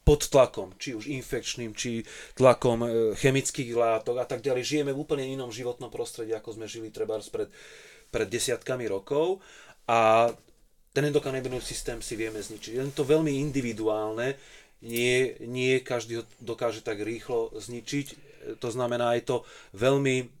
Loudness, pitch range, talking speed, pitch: -28 LUFS, 115-145 Hz, 145 wpm, 125 Hz